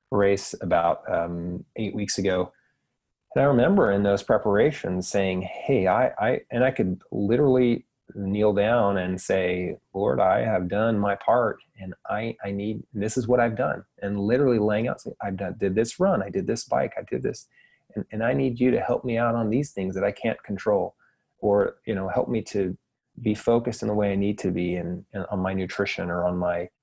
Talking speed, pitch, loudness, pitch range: 210 wpm, 100 Hz, -25 LUFS, 95-115 Hz